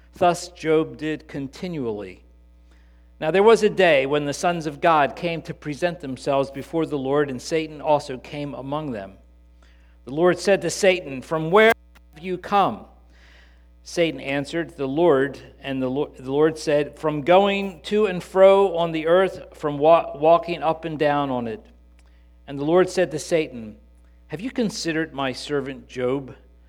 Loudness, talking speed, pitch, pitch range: -22 LUFS, 160 wpm, 150 Hz, 130-170 Hz